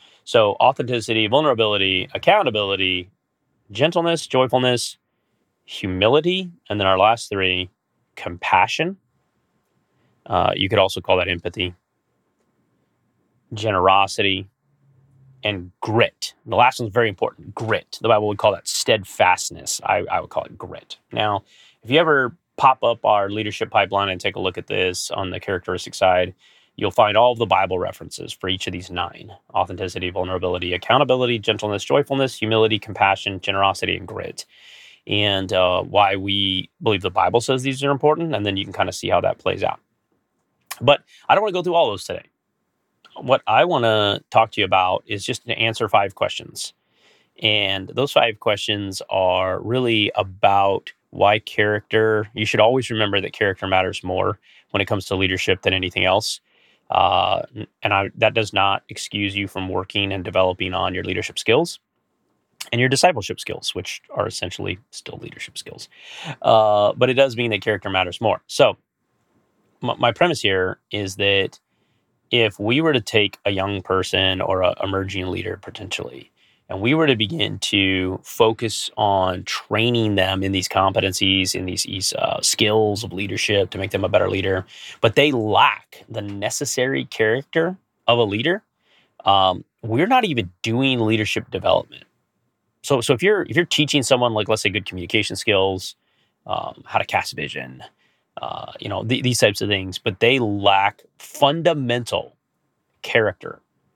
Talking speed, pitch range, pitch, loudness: 160 wpm, 95-115 Hz, 100 Hz, -20 LUFS